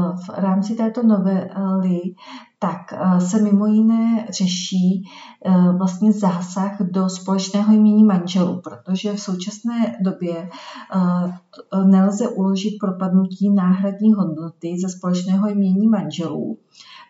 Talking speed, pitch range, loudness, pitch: 100 wpm, 185-205 Hz, -19 LUFS, 190 Hz